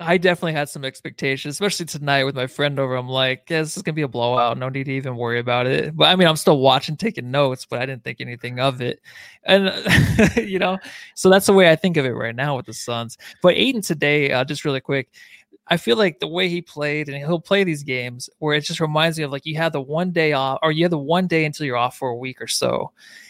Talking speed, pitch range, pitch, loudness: 270 wpm, 130-170 Hz, 145 Hz, -20 LUFS